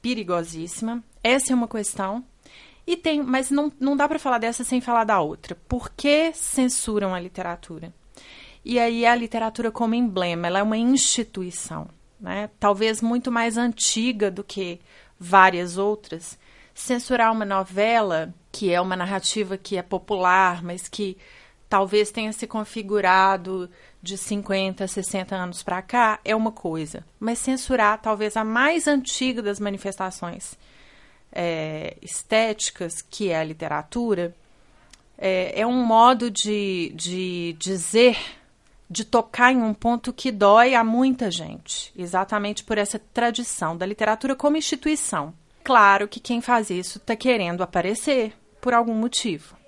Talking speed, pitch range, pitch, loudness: 140 wpm, 185-235 Hz, 210 Hz, -22 LUFS